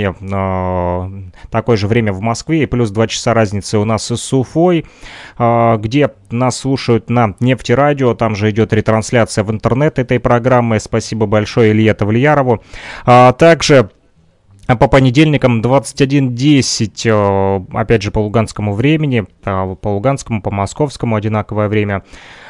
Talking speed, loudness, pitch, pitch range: 125 wpm, -13 LUFS, 115 Hz, 105-130 Hz